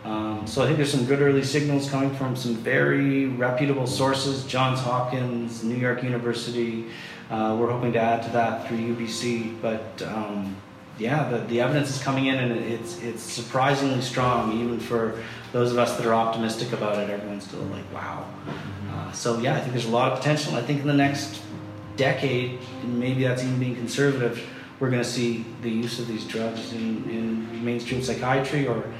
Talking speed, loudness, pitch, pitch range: 190 wpm, -25 LUFS, 120 Hz, 115-130 Hz